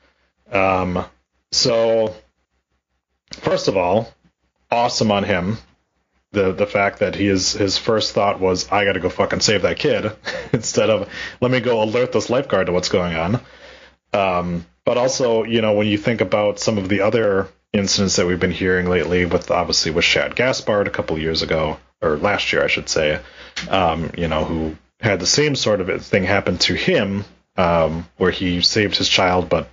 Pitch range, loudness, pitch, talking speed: 80-105 Hz, -18 LUFS, 95 Hz, 185 wpm